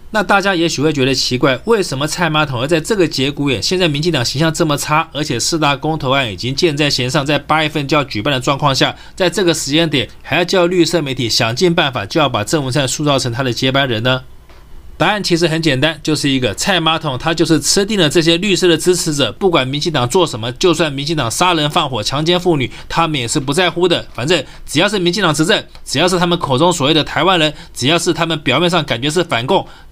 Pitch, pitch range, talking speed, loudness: 155 Hz, 135-175 Hz, 365 characters per minute, -14 LUFS